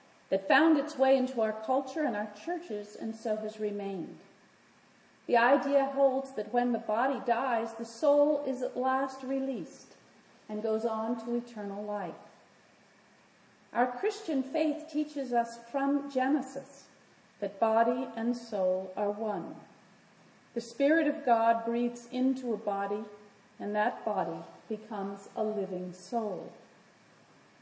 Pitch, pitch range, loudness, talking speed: 235 Hz, 210-270 Hz, -31 LUFS, 135 wpm